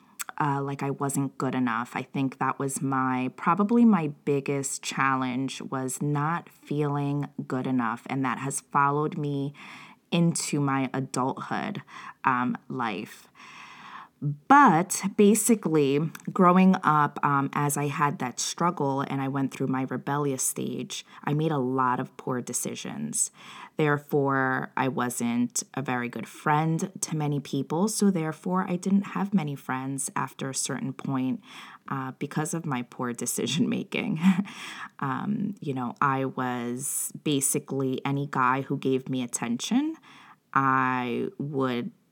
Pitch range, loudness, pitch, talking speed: 130-175 Hz, -27 LUFS, 140 Hz, 135 wpm